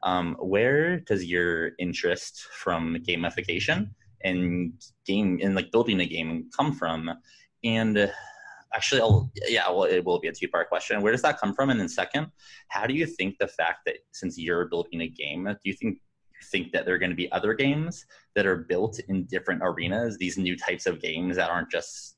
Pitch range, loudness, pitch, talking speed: 90-120 Hz, -27 LUFS, 95 Hz, 200 wpm